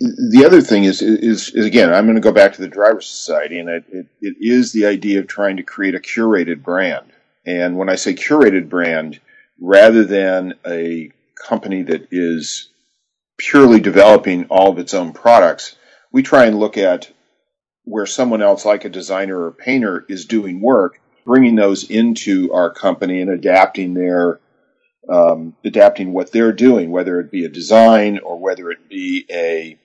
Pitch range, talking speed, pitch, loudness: 90-125 Hz, 180 wpm, 100 Hz, -14 LUFS